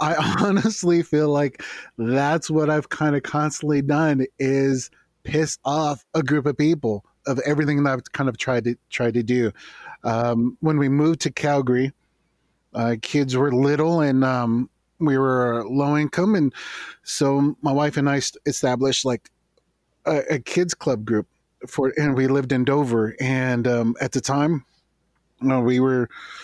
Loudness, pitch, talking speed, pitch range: -22 LUFS, 140 Hz, 170 wpm, 125-150 Hz